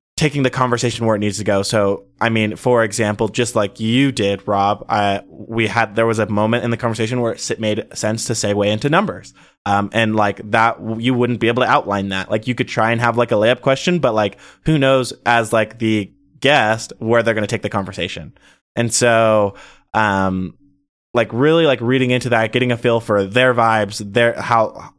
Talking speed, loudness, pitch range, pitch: 210 wpm, -17 LUFS, 105-120 Hz, 115 Hz